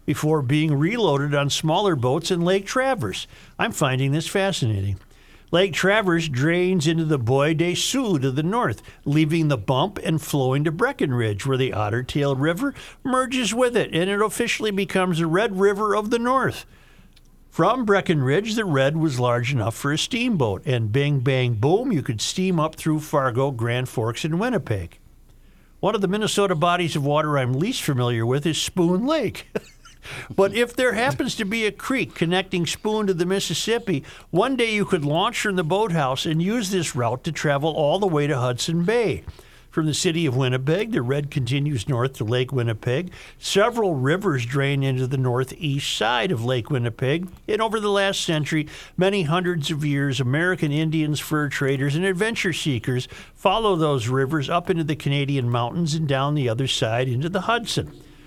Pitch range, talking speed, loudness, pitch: 135-190 Hz, 180 wpm, -22 LUFS, 155 Hz